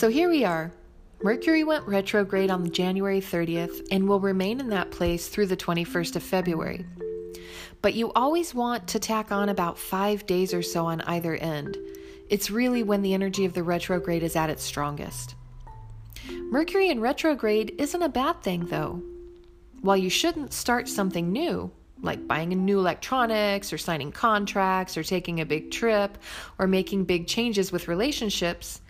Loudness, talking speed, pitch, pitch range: -26 LUFS, 165 wpm, 190 Hz, 170-220 Hz